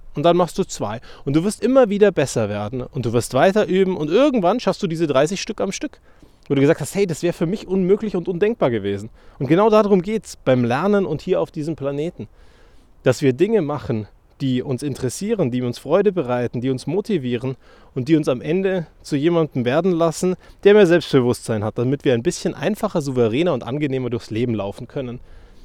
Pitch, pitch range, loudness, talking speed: 150 Hz, 125-190 Hz, -20 LUFS, 210 wpm